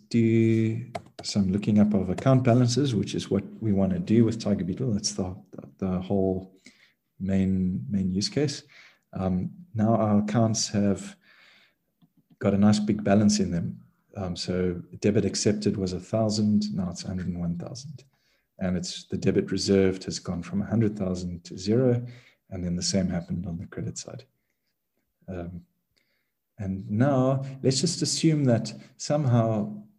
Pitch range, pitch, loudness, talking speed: 95-115 Hz, 105 Hz, -26 LUFS, 150 wpm